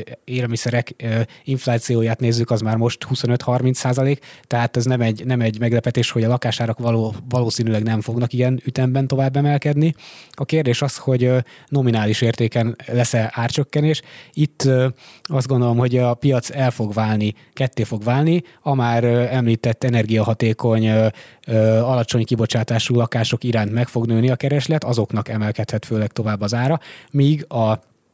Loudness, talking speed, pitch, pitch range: -19 LUFS, 145 wpm, 120 Hz, 115-130 Hz